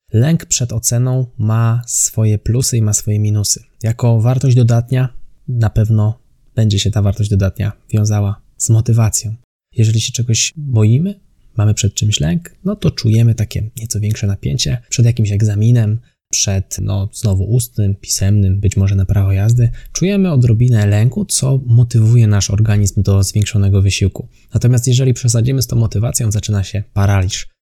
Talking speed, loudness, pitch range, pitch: 150 wpm, -14 LUFS, 105-120 Hz, 110 Hz